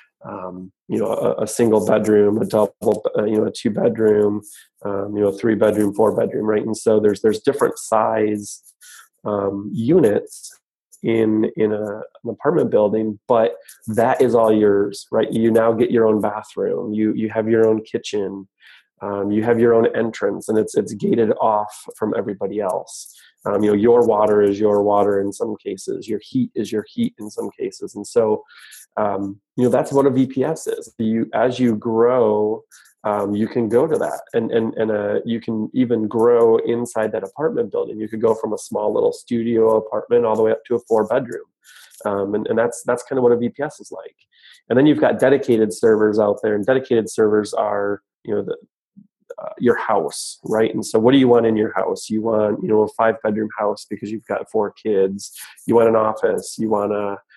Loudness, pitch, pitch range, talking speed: -19 LUFS, 110 Hz, 105-120 Hz, 205 wpm